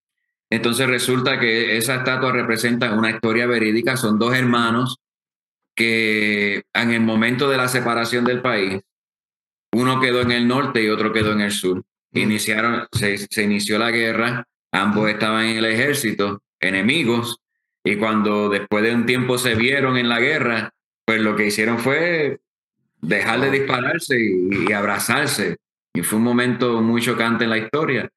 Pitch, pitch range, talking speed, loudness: 115 Hz, 110-125 Hz, 160 wpm, -19 LUFS